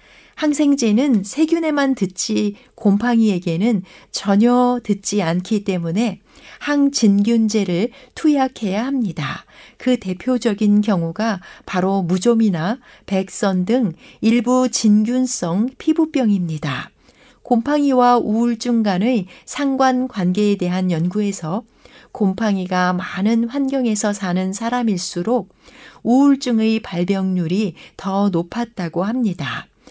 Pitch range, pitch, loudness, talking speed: 190-245 Hz, 215 Hz, -18 LUFS, 235 characters per minute